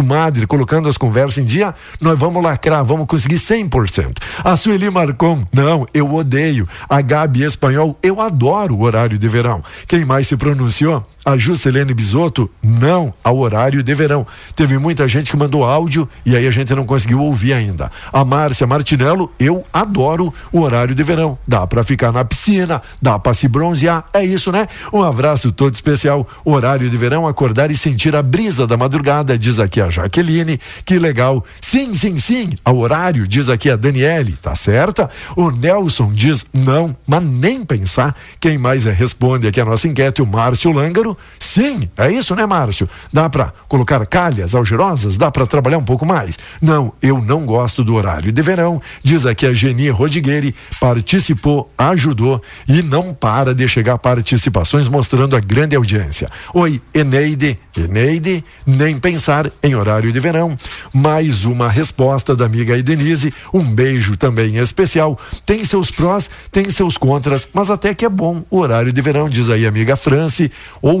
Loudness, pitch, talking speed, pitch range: -14 LUFS, 140 Hz, 170 wpm, 125-160 Hz